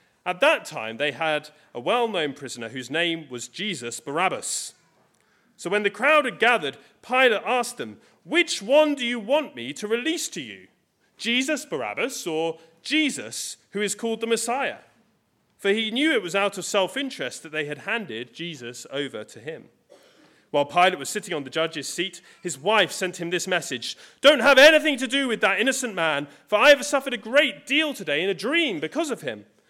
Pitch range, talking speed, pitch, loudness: 160-265 Hz, 195 wpm, 205 Hz, -23 LUFS